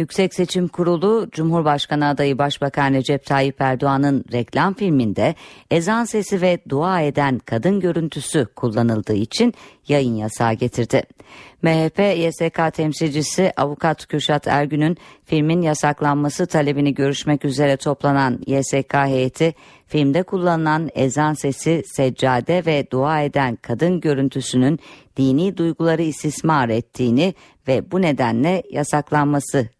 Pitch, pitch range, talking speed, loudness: 145 Hz, 135-165 Hz, 110 wpm, -19 LUFS